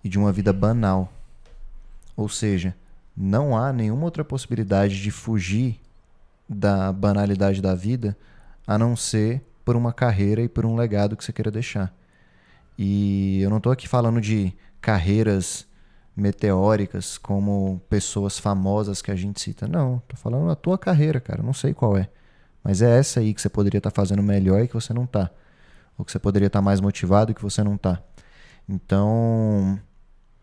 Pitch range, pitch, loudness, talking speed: 100-115 Hz, 105 Hz, -23 LUFS, 175 wpm